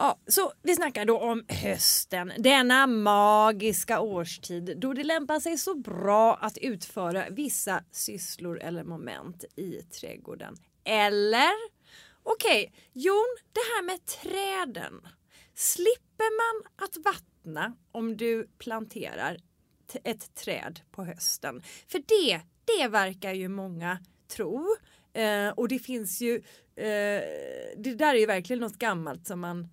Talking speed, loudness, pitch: 125 wpm, -27 LUFS, 230 Hz